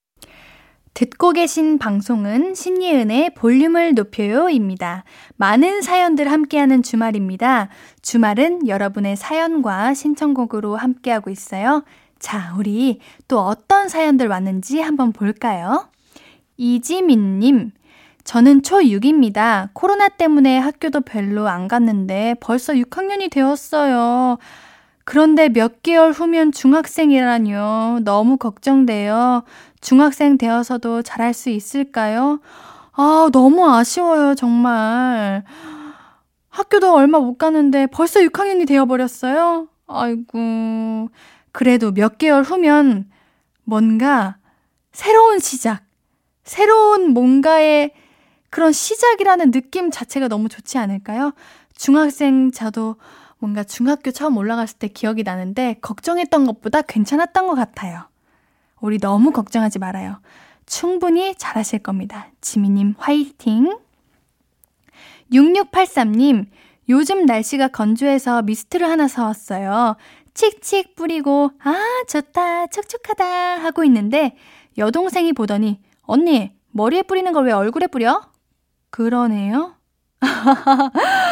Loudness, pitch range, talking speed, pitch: -16 LUFS, 225-315 Hz, 250 characters per minute, 265 Hz